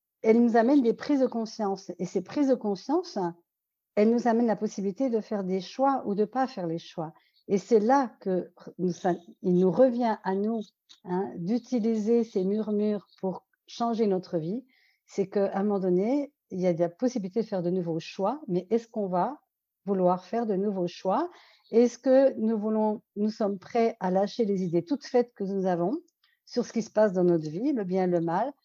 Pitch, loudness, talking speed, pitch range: 210 Hz, -27 LUFS, 205 wpm, 185-235 Hz